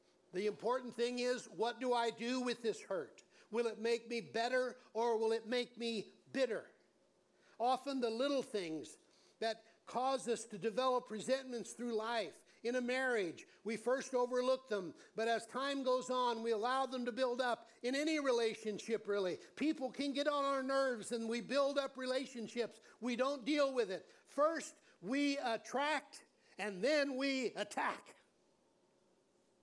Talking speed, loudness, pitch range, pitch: 160 wpm, -39 LUFS, 225-265 Hz, 245 Hz